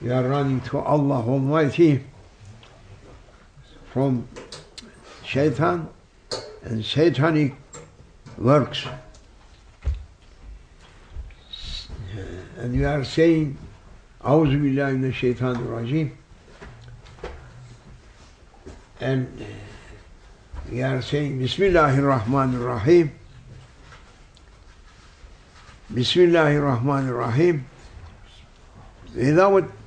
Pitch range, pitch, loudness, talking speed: 100-140 Hz, 125 Hz, -22 LUFS, 60 wpm